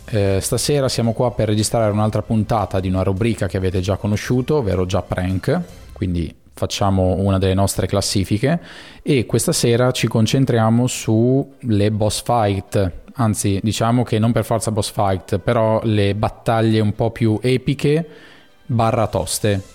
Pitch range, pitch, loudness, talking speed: 100-120 Hz, 110 Hz, -18 LUFS, 150 wpm